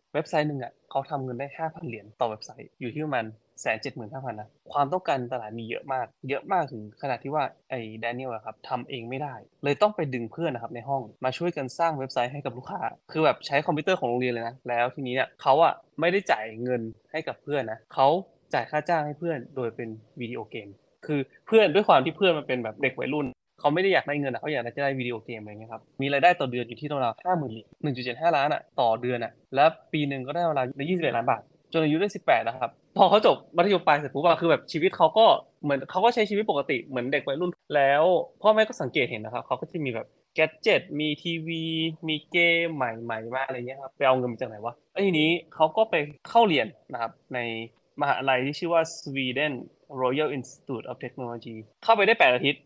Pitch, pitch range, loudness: 140 Hz, 125-160 Hz, -26 LUFS